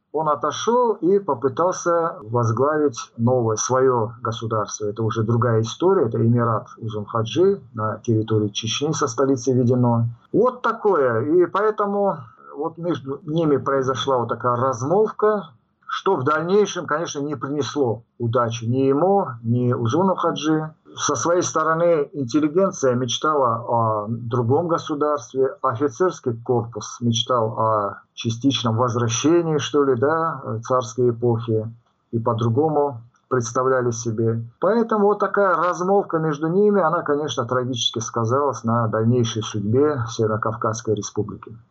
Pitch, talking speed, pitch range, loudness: 130 Hz, 120 wpm, 115-160 Hz, -21 LUFS